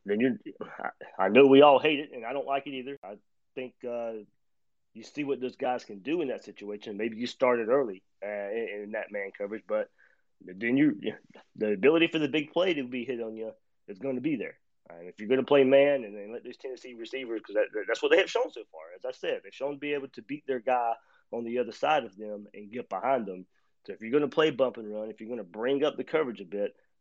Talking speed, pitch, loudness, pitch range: 270 wpm, 130 Hz, -28 LUFS, 110-155 Hz